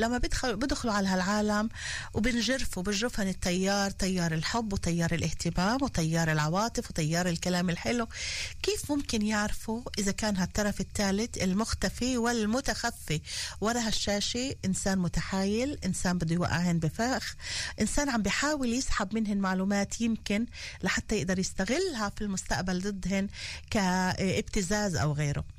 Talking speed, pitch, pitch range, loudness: 115 wpm, 205 Hz, 185-230 Hz, -30 LUFS